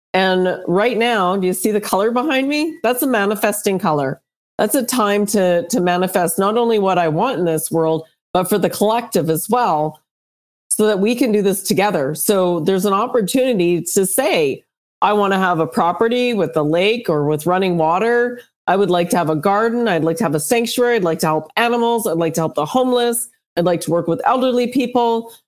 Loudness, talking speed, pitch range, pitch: -17 LUFS, 215 wpm, 170-235 Hz, 200 Hz